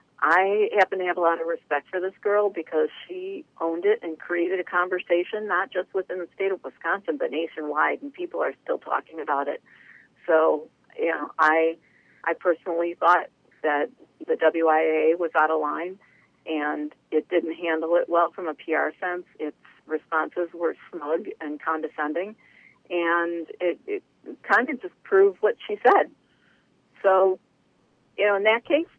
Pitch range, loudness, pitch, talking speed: 160-195 Hz, -25 LUFS, 175 Hz, 170 wpm